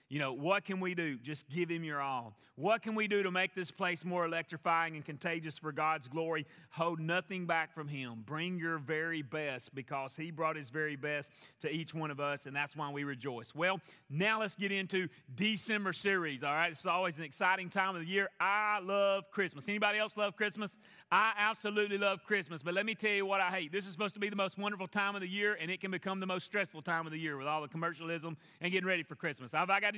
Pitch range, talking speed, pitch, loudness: 155-195 Hz, 240 wpm, 175 Hz, -35 LUFS